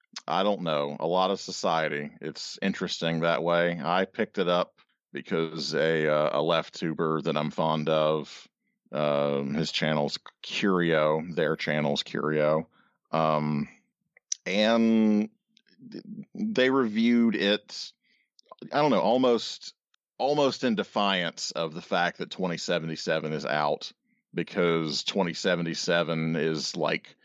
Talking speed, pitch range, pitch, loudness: 120 wpm, 75-100 Hz, 80 Hz, -27 LUFS